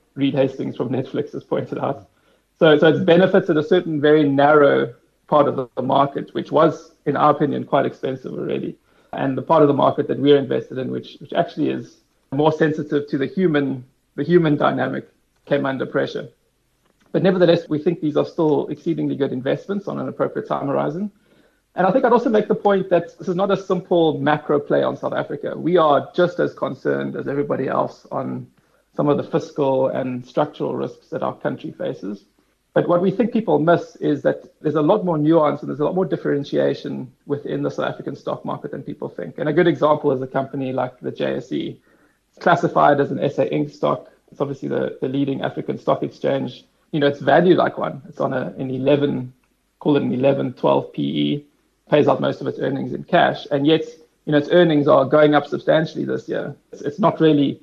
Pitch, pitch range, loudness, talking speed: 150 Hz, 135-170 Hz, -20 LUFS, 210 wpm